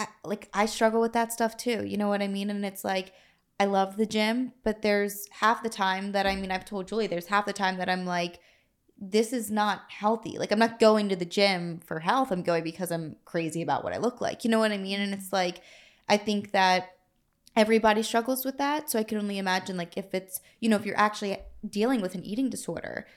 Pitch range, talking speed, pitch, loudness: 190-220 Hz, 245 wpm, 205 Hz, -28 LUFS